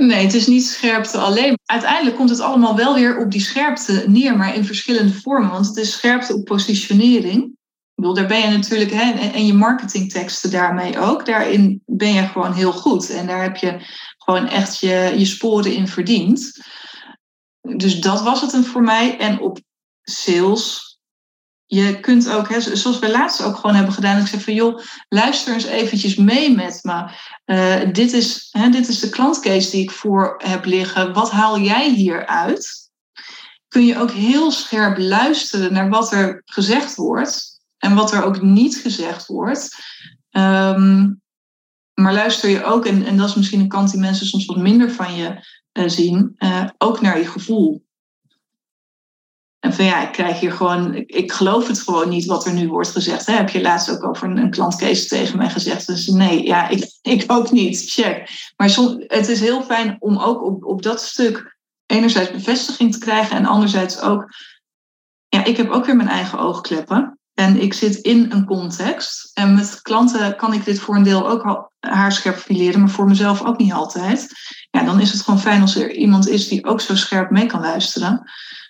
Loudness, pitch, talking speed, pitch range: -16 LUFS, 210 Hz, 195 wpm, 195-235 Hz